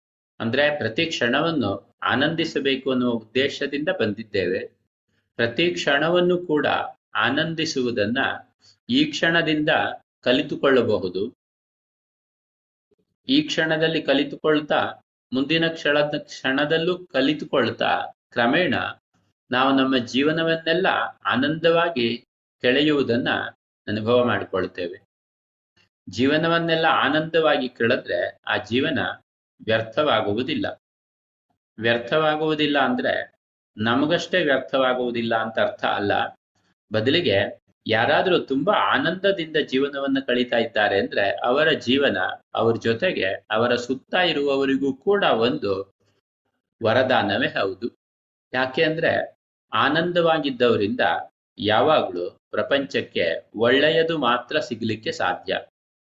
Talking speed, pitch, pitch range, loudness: 75 wpm, 140 Hz, 120-160 Hz, -22 LUFS